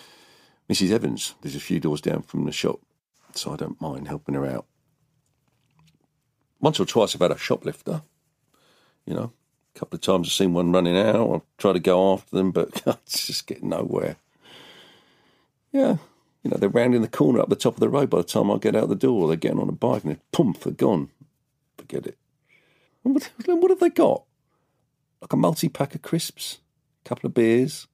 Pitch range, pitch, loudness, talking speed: 110-165 Hz, 140 Hz, -23 LUFS, 200 wpm